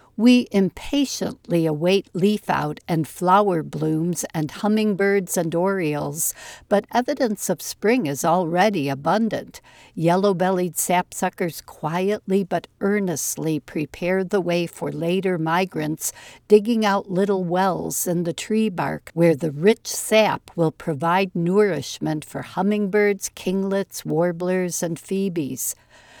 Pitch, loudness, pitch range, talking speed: 185 Hz, -22 LUFS, 165-200 Hz, 120 wpm